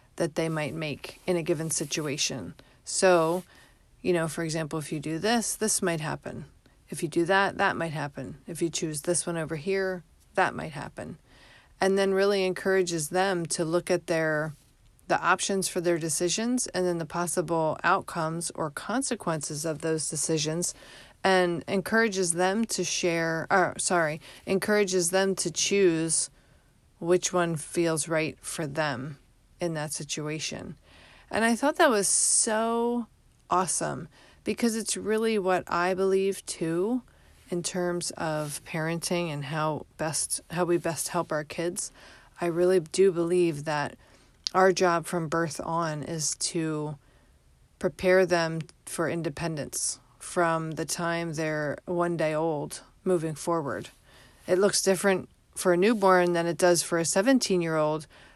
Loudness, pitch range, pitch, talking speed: -27 LUFS, 160-185 Hz, 170 Hz, 150 wpm